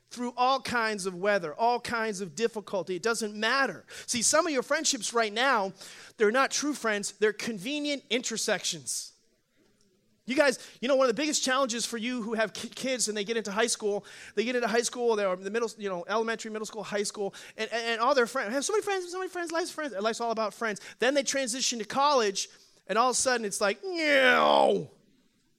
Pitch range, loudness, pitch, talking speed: 210-265 Hz, -28 LUFS, 230 Hz, 220 wpm